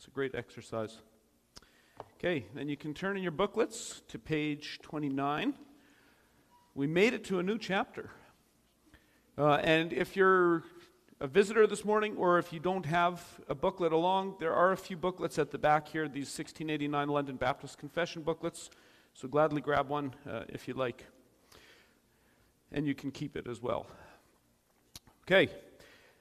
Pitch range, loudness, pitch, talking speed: 140-185 Hz, -32 LUFS, 155 Hz, 160 wpm